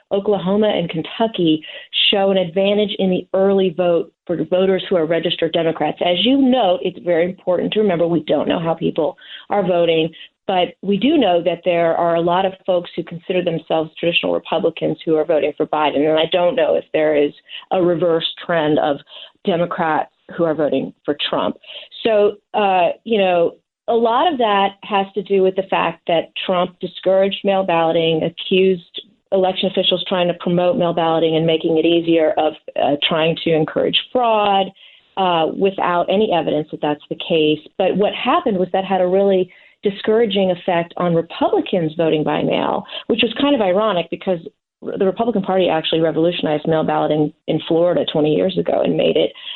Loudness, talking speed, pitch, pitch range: -17 LUFS, 180 wpm, 180 Hz, 165-200 Hz